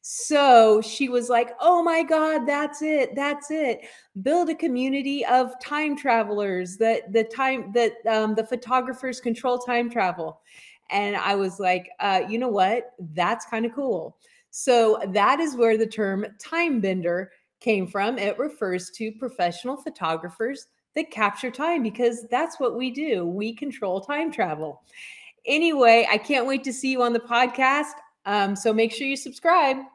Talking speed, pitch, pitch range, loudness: 165 wpm, 245 Hz, 220-285 Hz, -23 LUFS